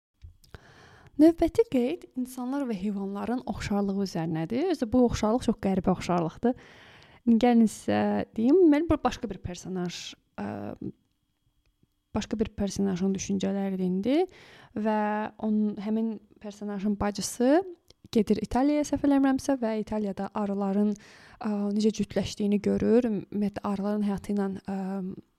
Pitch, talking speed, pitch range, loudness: 210 Hz, 115 wpm, 195-245 Hz, -27 LUFS